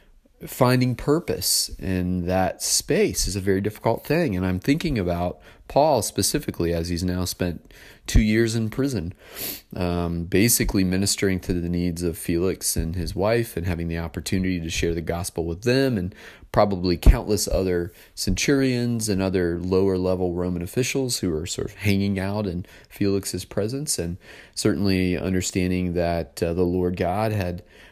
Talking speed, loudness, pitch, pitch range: 160 wpm, -23 LUFS, 95 Hz, 85-105 Hz